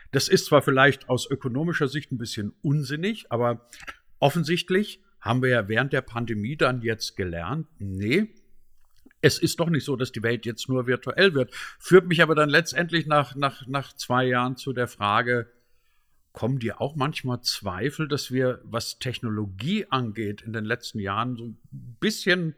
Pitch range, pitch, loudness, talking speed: 120-150 Hz, 130 Hz, -25 LUFS, 170 wpm